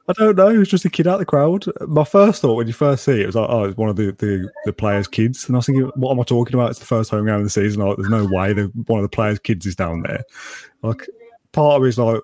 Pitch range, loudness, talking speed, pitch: 105-145 Hz, -18 LUFS, 325 wpm, 115 Hz